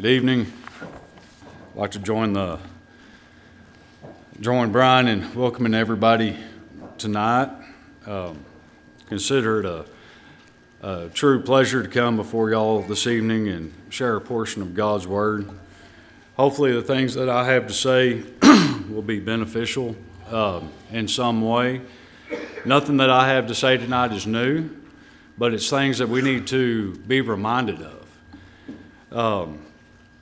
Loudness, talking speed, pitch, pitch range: -21 LUFS, 135 wpm, 115 Hz, 100-125 Hz